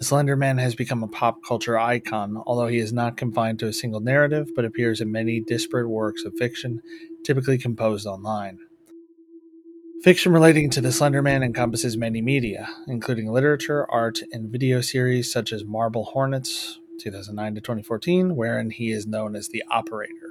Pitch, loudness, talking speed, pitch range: 120 Hz, -23 LUFS, 165 wpm, 110-145 Hz